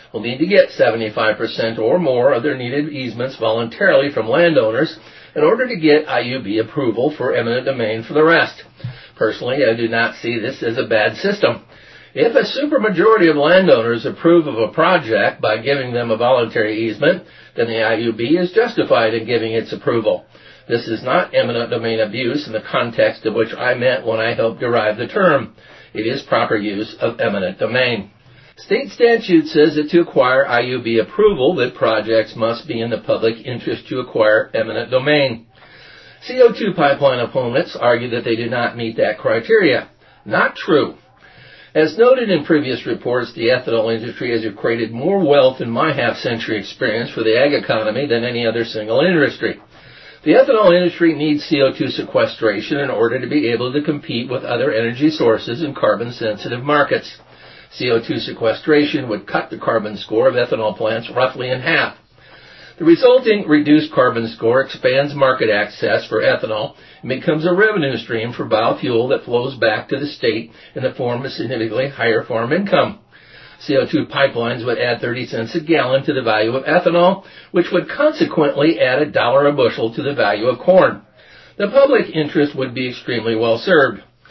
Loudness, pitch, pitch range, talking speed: -16 LUFS, 140 Hz, 115-175 Hz, 175 wpm